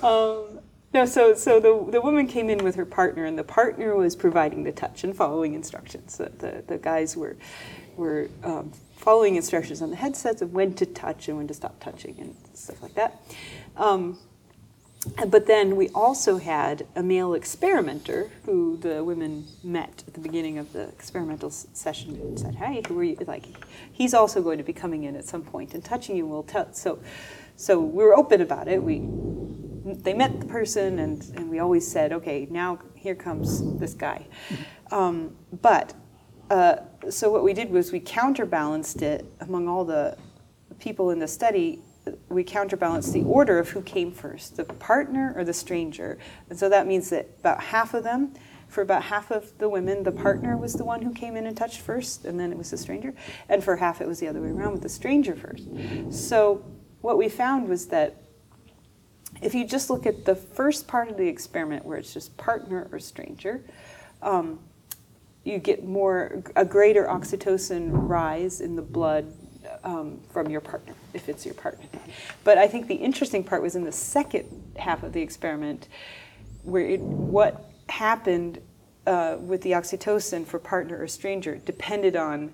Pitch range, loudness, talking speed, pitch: 170-240 Hz, -25 LUFS, 190 wpm, 190 Hz